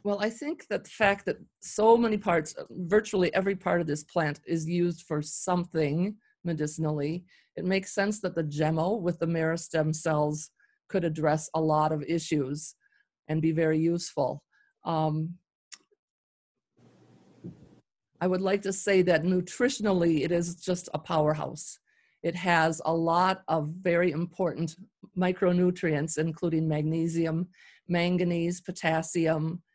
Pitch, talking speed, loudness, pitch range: 170 Hz, 135 wpm, -28 LUFS, 160-185 Hz